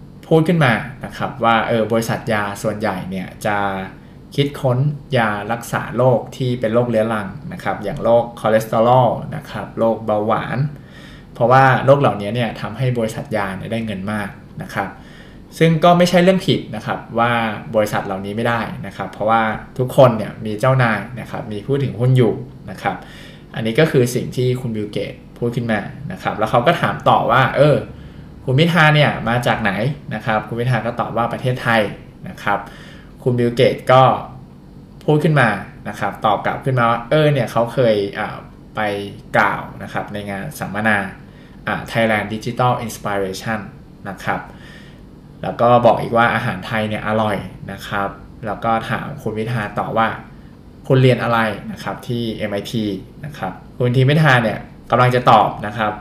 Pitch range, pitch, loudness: 105-130 Hz, 115 Hz, -18 LUFS